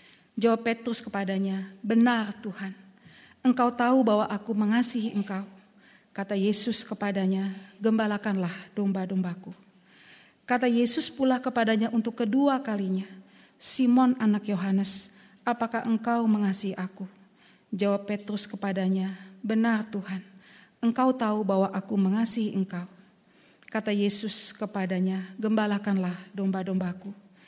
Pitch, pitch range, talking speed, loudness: 205 Hz, 195-225 Hz, 100 wpm, -27 LUFS